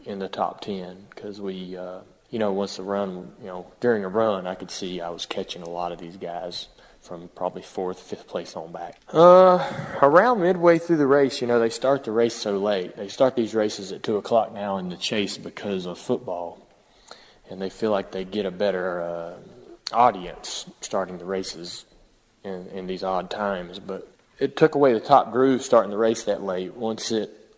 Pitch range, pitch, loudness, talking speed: 90-115 Hz, 100 Hz, -23 LUFS, 205 wpm